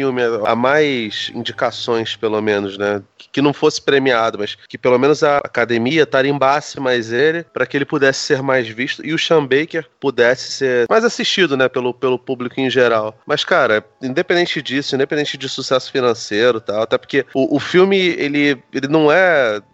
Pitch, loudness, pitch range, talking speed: 135 Hz, -16 LUFS, 120-150 Hz, 180 wpm